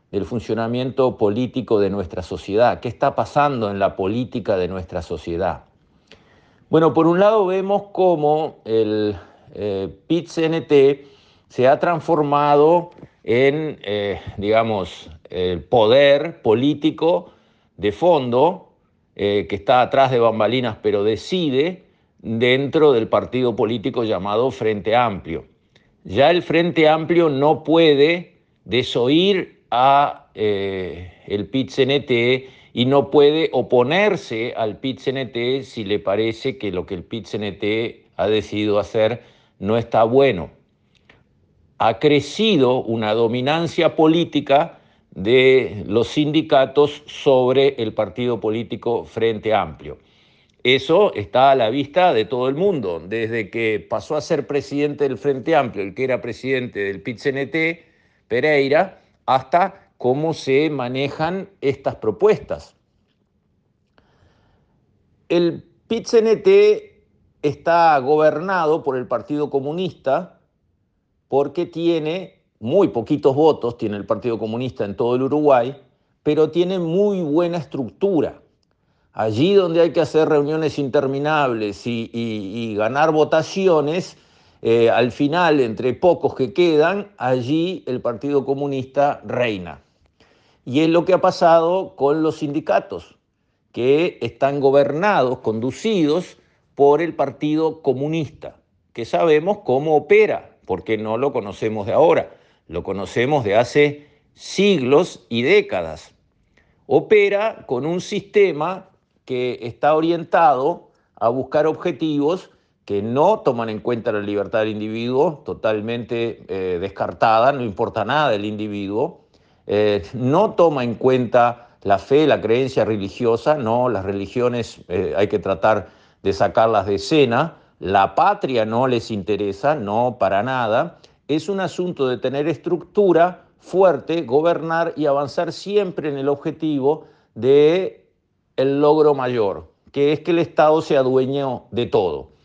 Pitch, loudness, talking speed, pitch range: 140 Hz, -19 LUFS, 125 wpm, 115-160 Hz